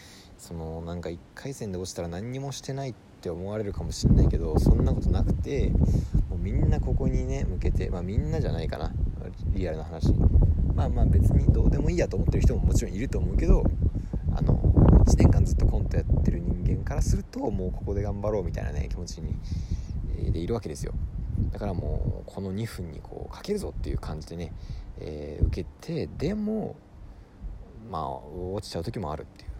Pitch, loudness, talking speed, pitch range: 90 Hz, -27 LUFS, 385 characters per minute, 80-100 Hz